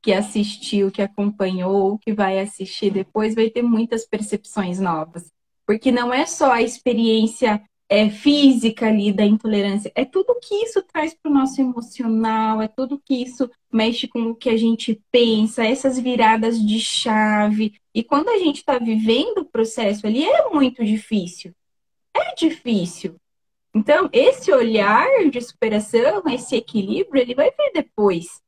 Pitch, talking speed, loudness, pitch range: 225 Hz, 155 wpm, -19 LUFS, 210-265 Hz